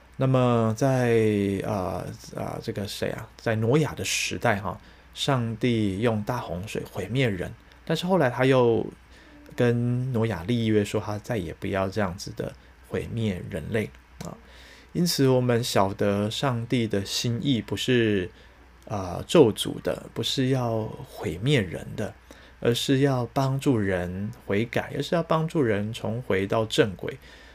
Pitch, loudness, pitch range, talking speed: 115 Hz, -26 LUFS, 105-130 Hz, 210 characters per minute